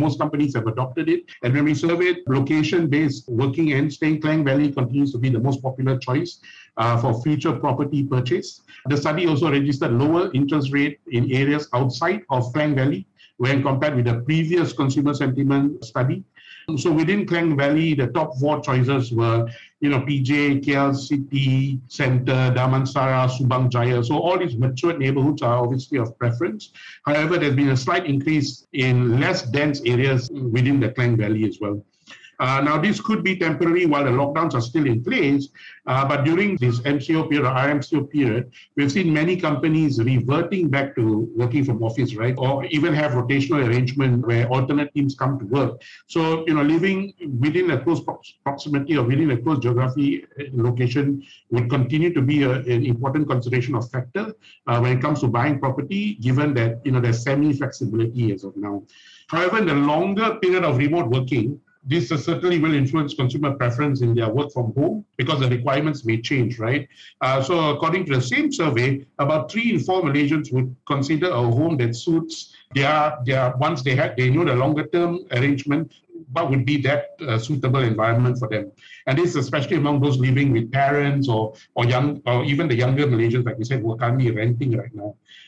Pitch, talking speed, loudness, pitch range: 140 Hz, 185 wpm, -21 LUFS, 125-155 Hz